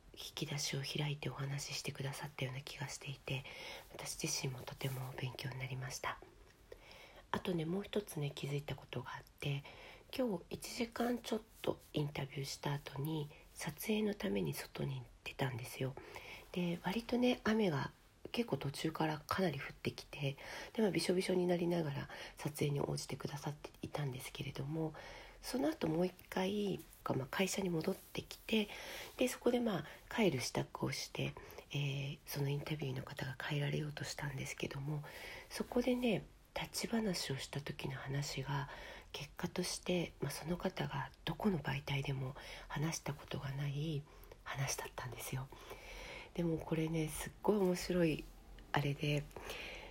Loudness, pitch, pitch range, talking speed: -41 LUFS, 150 Hz, 140-185 Hz, 330 characters per minute